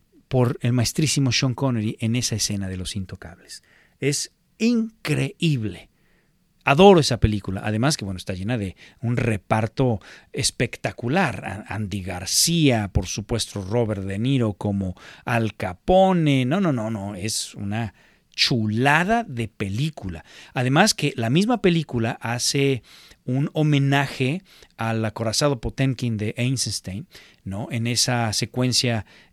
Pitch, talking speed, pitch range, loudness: 115 Hz, 125 wpm, 105-140 Hz, -22 LUFS